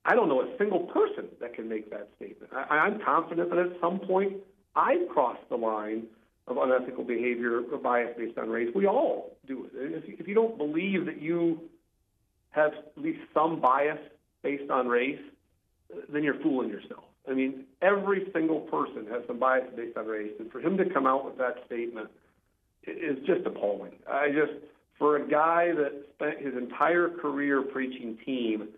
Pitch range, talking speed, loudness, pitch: 120-170 Hz, 180 wpm, -29 LUFS, 145 Hz